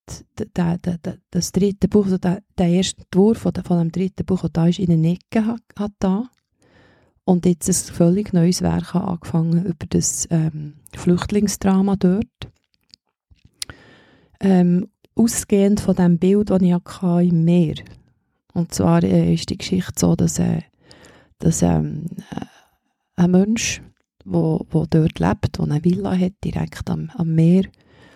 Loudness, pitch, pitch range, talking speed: -19 LUFS, 180 Hz, 170-190 Hz, 145 wpm